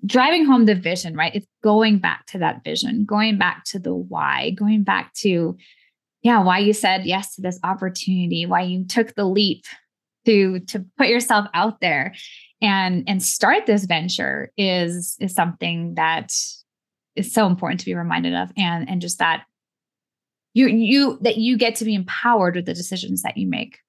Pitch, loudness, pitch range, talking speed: 195 Hz, -20 LUFS, 175-220 Hz, 180 wpm